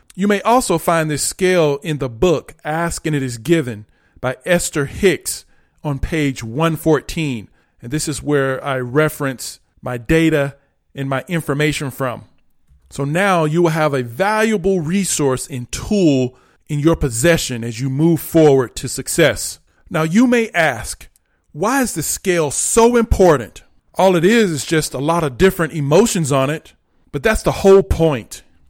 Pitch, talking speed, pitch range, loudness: 155 Hz, 165 wpm, 135-170 Hz, -17 LUFS